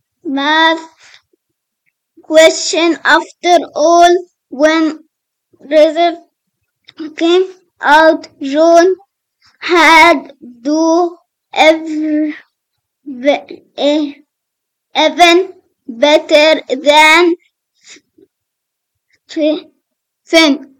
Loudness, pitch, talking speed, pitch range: -10 LUFS, 320 Hz, 50 wpm, 300-340 Hz